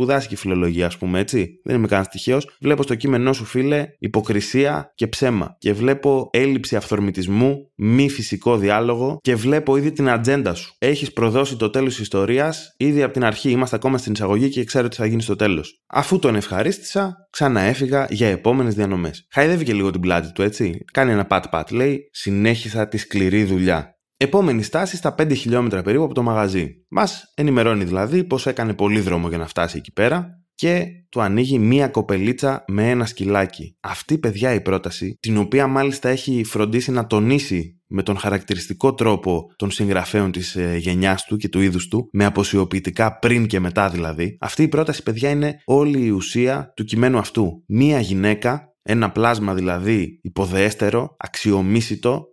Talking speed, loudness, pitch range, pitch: 170 wpm, -20 LUFS, 100-135 Hz, 115 Hz